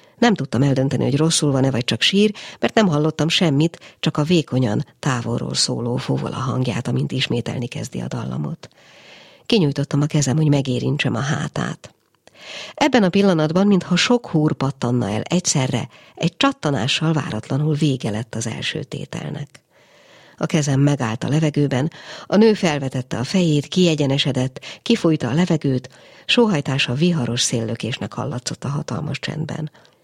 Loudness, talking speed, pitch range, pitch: -20 LUFS, 140 wpm, 130-165 Hz, 145 Hz